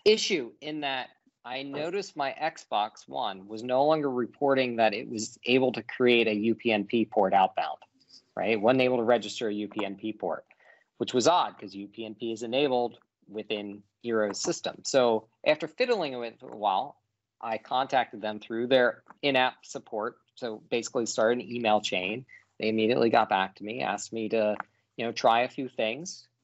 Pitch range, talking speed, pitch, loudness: 110-130 Hz, 170 wpm, 115 Hz, -28 LUFS